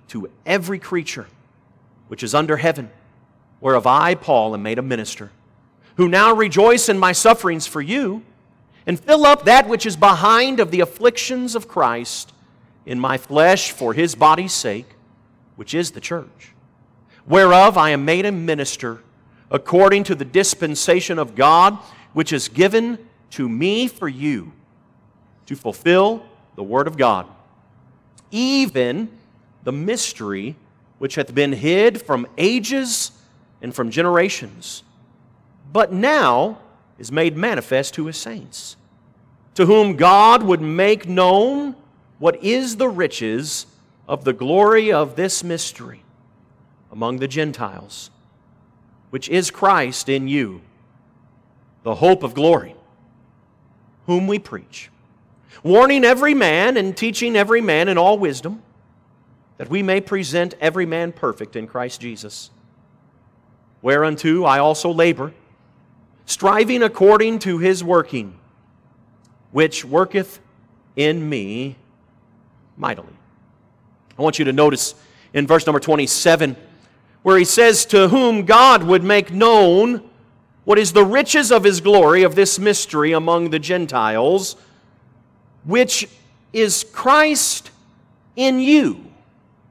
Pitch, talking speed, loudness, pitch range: 160 Hz, 130 wpm, -16 LUFS, 125-200 Hz